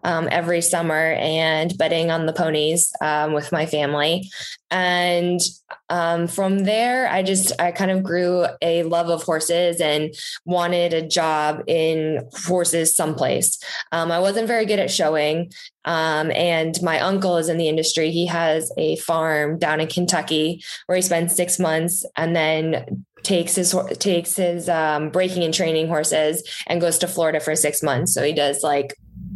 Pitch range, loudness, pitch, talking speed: 155-180 Hz, -20 LUFS, 170 Hz, 170 wpm